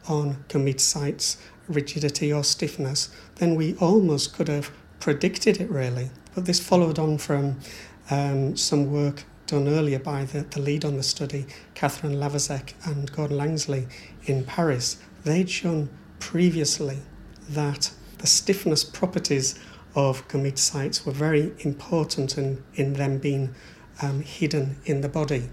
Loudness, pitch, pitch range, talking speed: -25 LUFS, 145 Hz, 140-155 Hz, 140 wpm